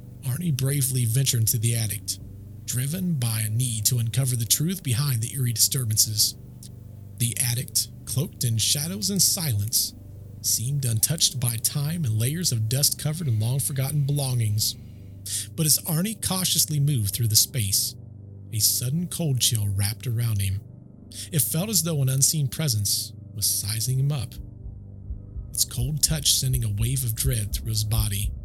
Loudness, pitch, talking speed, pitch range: -23 LUFS, 120 Hz, 155 wpm, 110-135 Hz